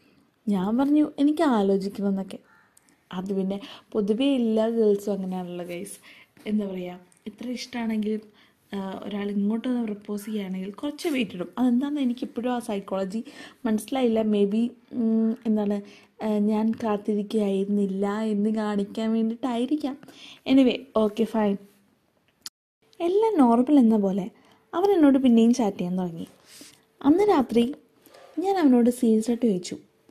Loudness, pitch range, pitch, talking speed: -25 LUFS, 205-250 Hz, 220 Hz, 110 wpm